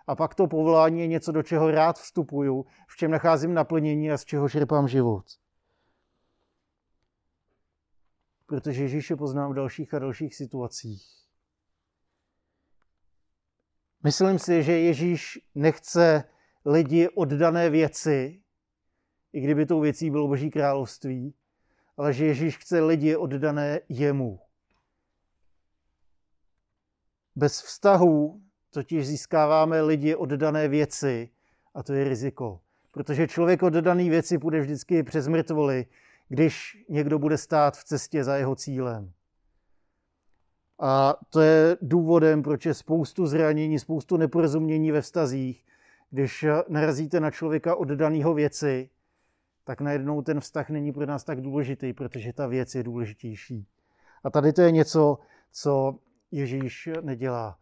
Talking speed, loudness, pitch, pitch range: 125 wpm, -25 LUFS, 150 Hz, 130-160 Hz